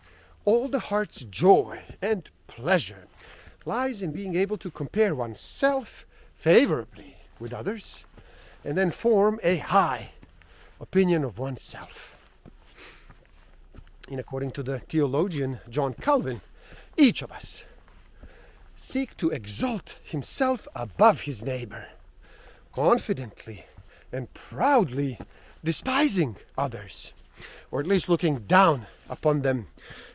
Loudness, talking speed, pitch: -26 LUFS, 105 wpm, 150 Hz